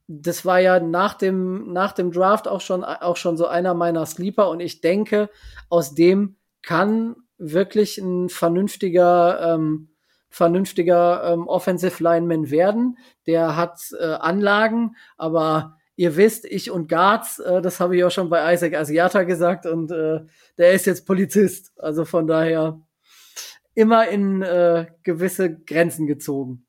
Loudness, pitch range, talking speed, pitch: -20 LUFS, 165-190 Hz, 150 wpm, 175 Hz